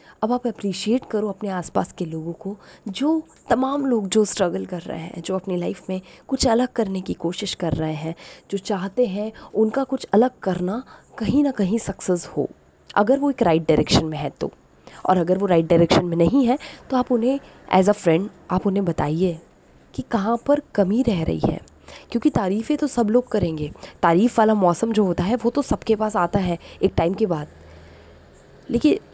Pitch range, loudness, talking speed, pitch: 175-235 Hz, -22 LUFS, 200 wpm, 200 Hz